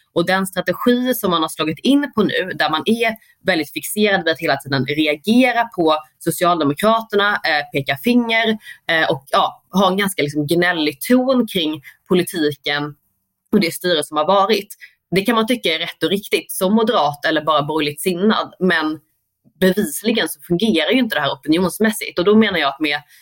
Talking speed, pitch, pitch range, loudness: 180 wpm, 180 Hz, 155-220 Hz, -17 LUFS